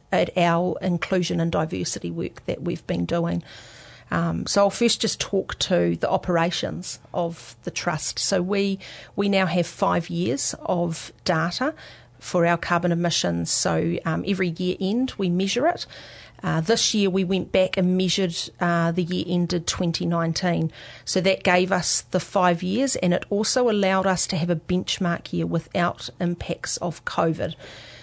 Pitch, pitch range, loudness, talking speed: 175 Hz, 165-190 Hz, -23 LUFS, 165 wpm